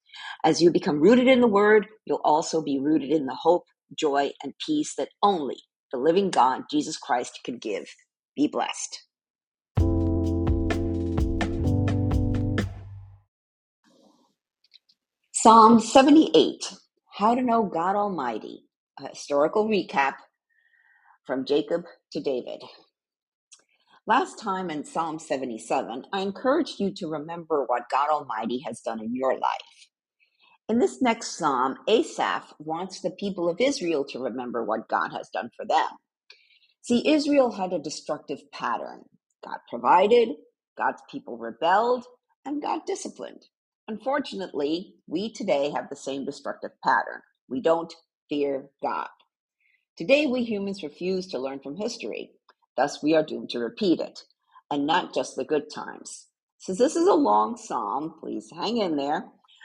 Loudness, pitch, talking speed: -25 LUFS, 190 Hz, 135 wpm